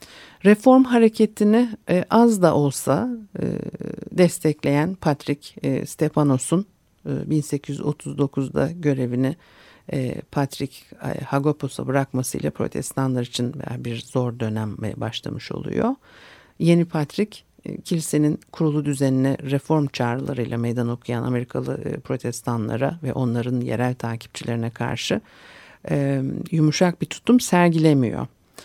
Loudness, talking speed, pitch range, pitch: -22 LUFS, 85 wpm, 125-170 Hz, 145 Hz